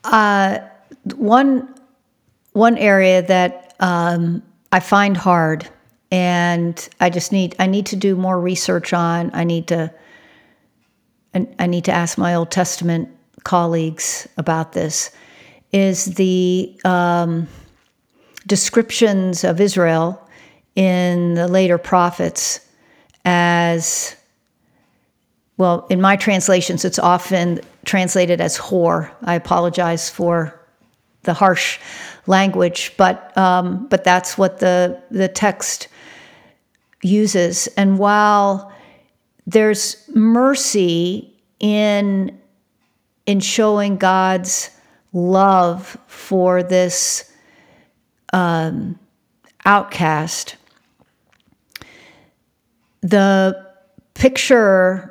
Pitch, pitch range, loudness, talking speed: 185 Hz, 175-200 Hz, -16 LUFS, 90 wpm